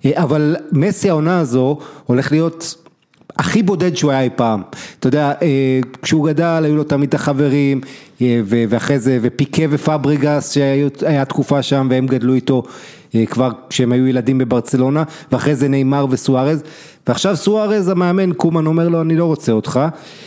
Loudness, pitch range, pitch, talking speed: -16 LUFS, 130-160 Hz, 145 Hz, 150 wpm